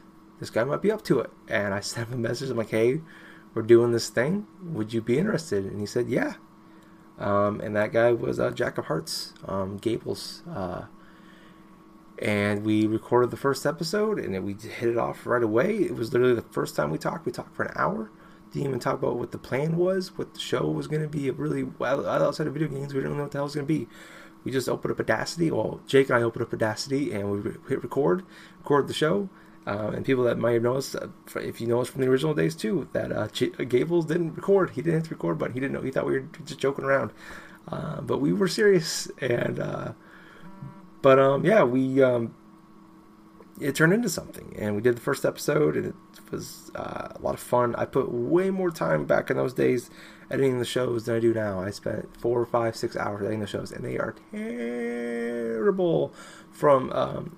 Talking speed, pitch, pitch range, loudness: 225 wpm, 125 Hz, 115-155 Hz, -26 LUFS